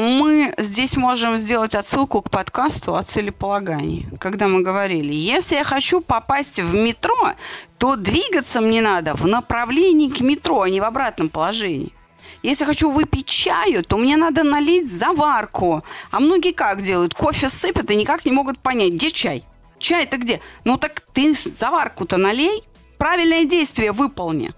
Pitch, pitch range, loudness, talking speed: 270 Hz, 210-310 Hz, -18 LUFS, 155 wpm